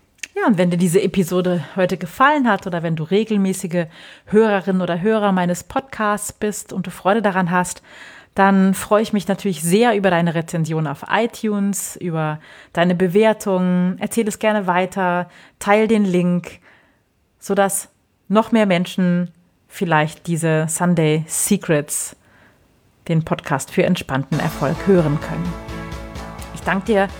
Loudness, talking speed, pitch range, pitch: -19 LUFS, 140 wpm, 170-205 Hz, 185 Hz